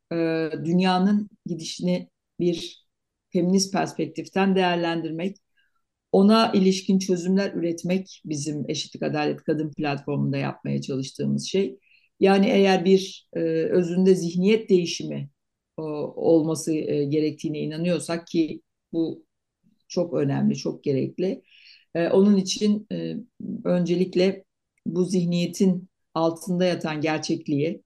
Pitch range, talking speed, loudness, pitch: 155-190 Hz, 90 wpm, -24 LUFS, 170 Hz